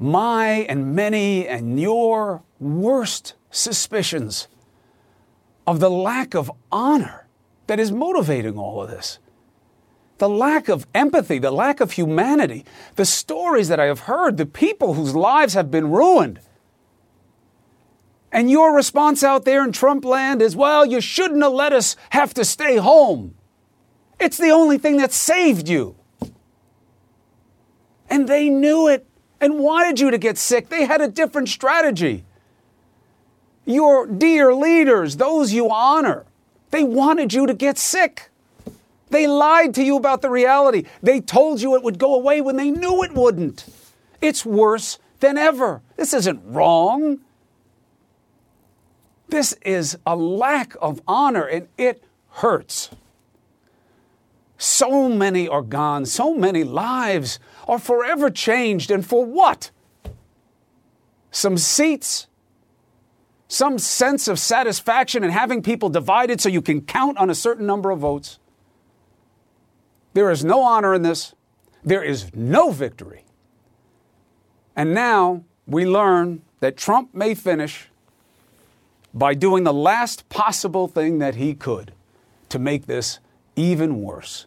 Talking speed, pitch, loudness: 135 wpm, 205 Hz, -18 LUFS